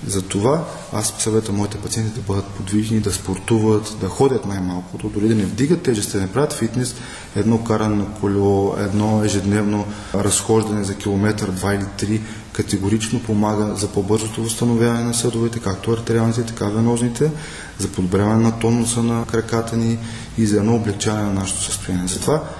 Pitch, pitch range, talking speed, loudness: 105 Hz, 100-115 Hz, 160 wpm, -20 LUFS